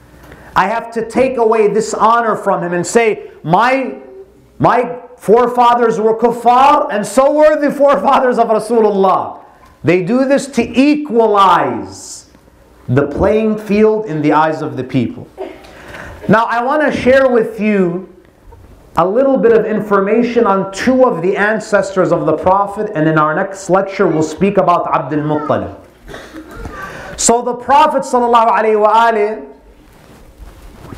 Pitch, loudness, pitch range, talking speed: 215 Hz, -12 LUFS, 190-245 Hz, 135 wpm